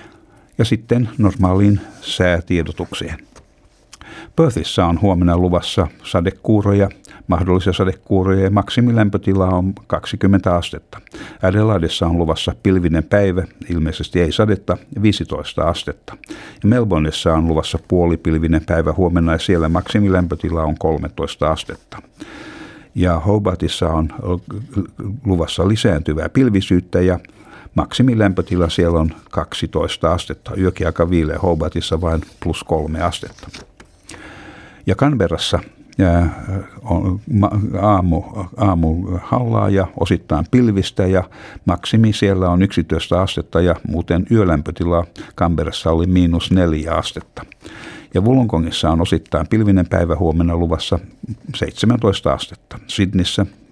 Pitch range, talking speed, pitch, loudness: 85-100 Hz, 100 wpm, 90 Hz, -17 LUFS